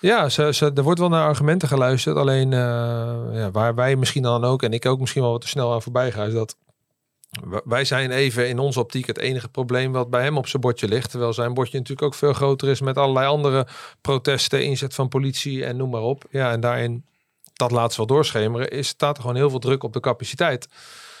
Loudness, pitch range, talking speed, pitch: -21 LUFS, 120-140 Hz, 235 wpm, 130 Hz